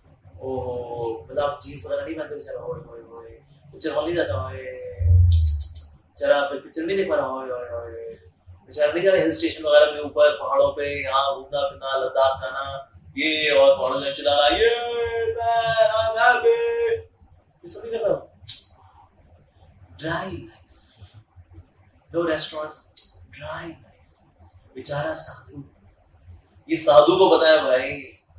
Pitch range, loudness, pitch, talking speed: 95-160 Hz, -22 LUFS, 135 Hz, 30 wpm